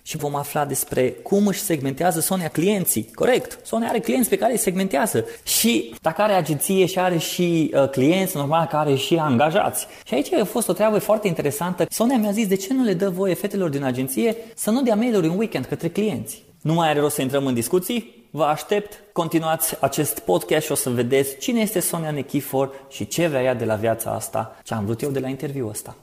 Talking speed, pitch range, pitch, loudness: 215 wpm, 135-200 Hz, 165 Hz, -21 LUFS